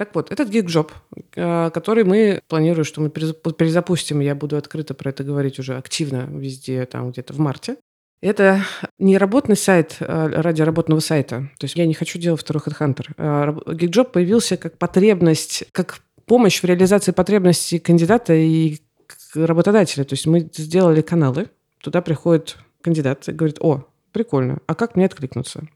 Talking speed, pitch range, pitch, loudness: 155 wpm, 150-180 Hz, 160 Hz, -18 LUFS